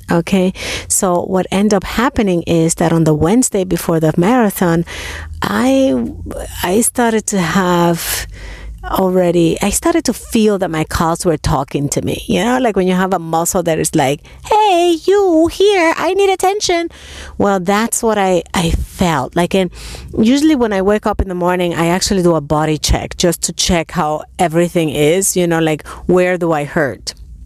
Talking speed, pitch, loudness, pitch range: 180 wpm, 180 Hz, -14 LUFS, 165-225 Hz